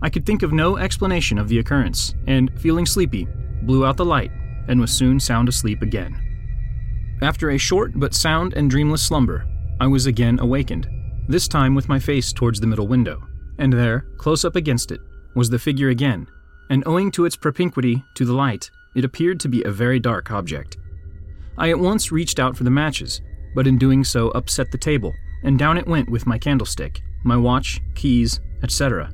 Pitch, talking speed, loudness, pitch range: 125 Hz, 195 wpm, -20 LUFS, 115-140 Hz